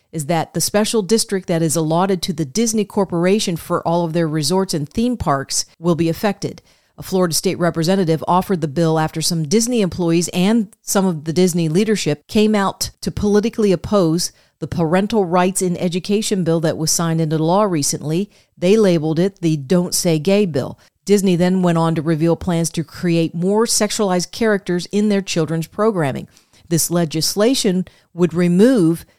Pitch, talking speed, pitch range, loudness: 180 Hz, 175 wpm, 165-200 Hz, -17 LUFS